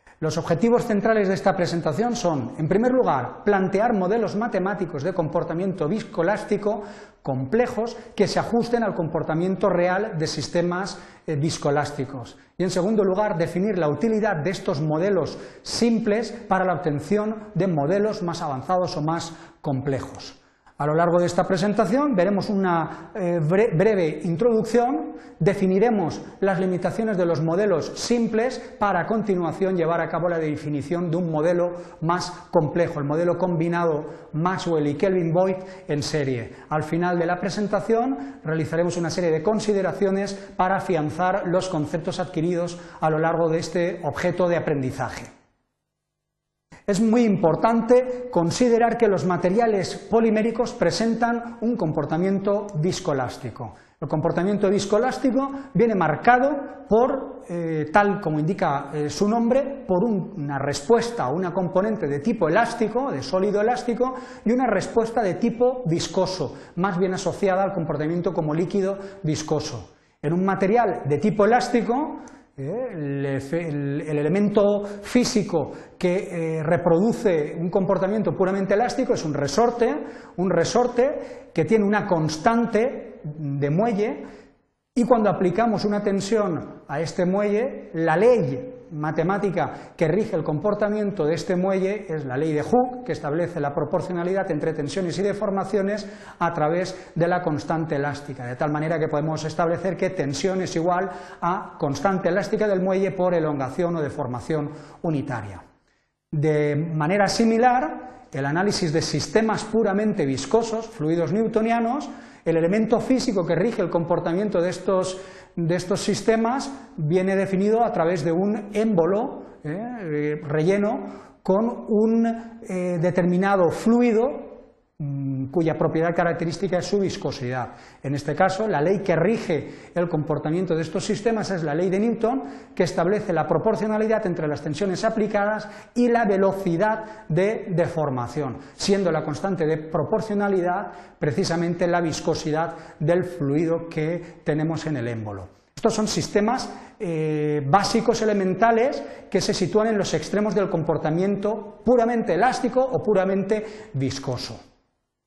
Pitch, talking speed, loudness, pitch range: 185 Hz, 135 wpm, -23 LUFS, 160-215 Hz